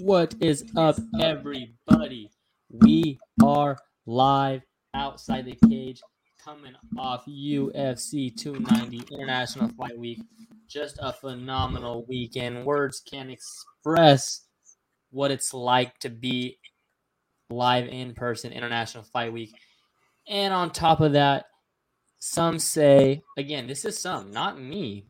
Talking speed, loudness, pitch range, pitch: 115 wpm, -24 LUFS, 125-160 Hz, 135 Hz